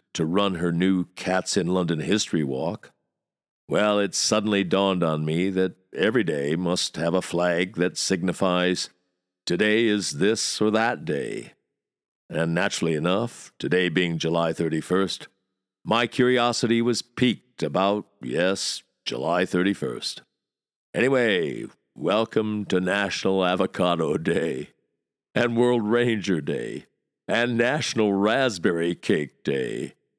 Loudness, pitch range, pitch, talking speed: -24 LUFS, 90-105 Hz, 95 Hz, 120 wpm